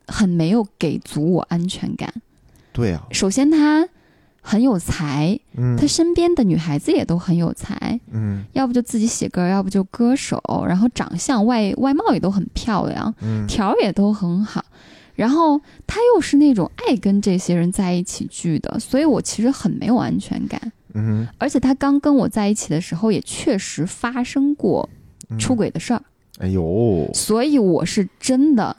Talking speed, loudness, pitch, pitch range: 250 characters per minute, -19 LUFS, 215 Hz, 175-260 Hz